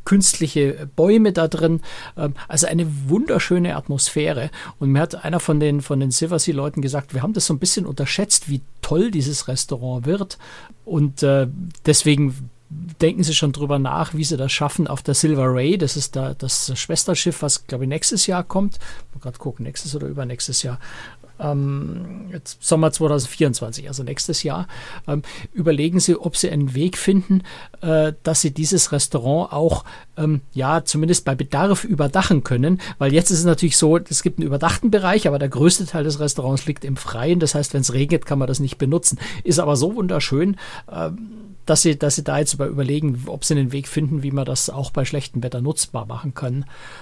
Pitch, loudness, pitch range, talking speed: 150 Hz, -19 LUFS, 140-170 Hz, 185 wpm